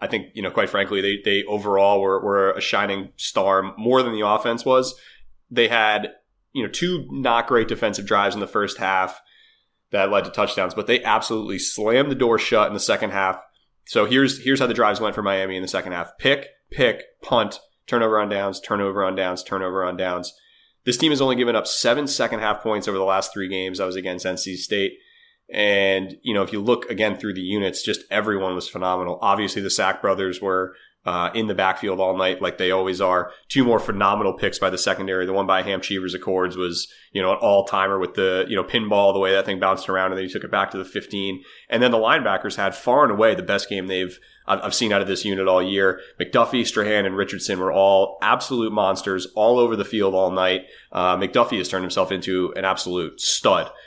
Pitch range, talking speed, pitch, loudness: 95-110 Hz, 225 wpm, 95 Hz, -21 LUFS